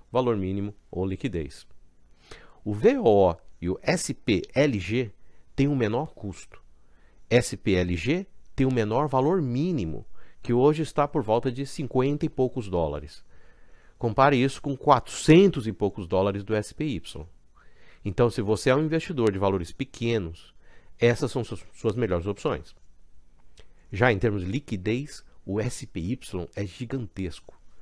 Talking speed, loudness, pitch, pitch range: 135 wpm, -26 LUFS, 110 Hz, 95-130 Hz